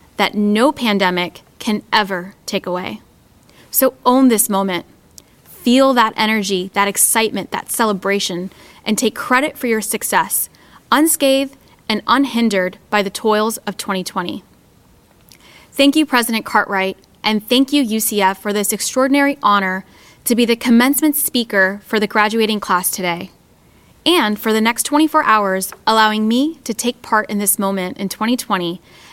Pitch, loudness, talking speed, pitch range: 215 Hz, -16 LUFS, 145 wpm, 195-245 Hz